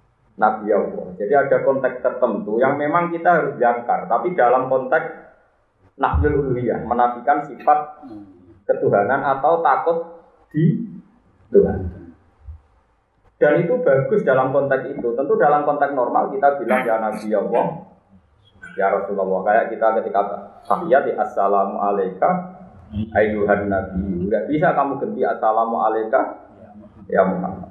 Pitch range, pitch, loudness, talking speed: 100-160 Hz, 120 Hz, -19 LUFS, 115 wpm